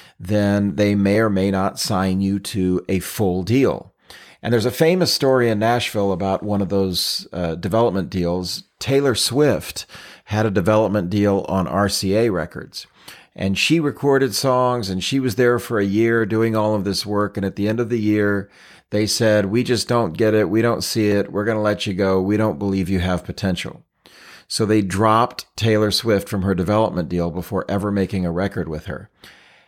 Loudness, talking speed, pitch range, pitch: -19 LUFS, 195 wpm, 95-115 Hz, 105 Hz